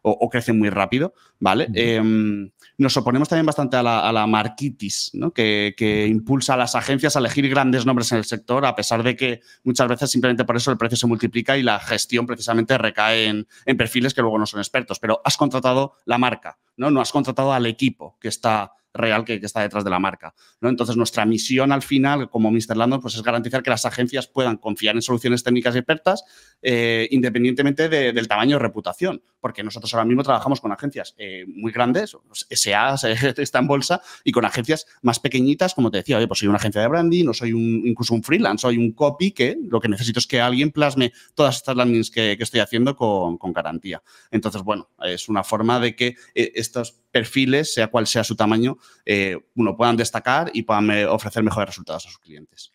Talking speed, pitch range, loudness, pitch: 215 wpm, 110-130 Hz, -20 LUFS, 120 Hz